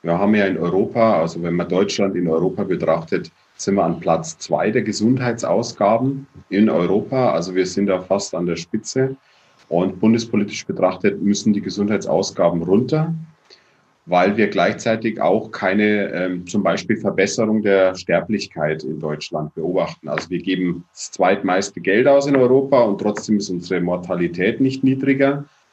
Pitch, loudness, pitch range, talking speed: 100 Hz, -19 LUFS, 90-115 Hz, 155 wpm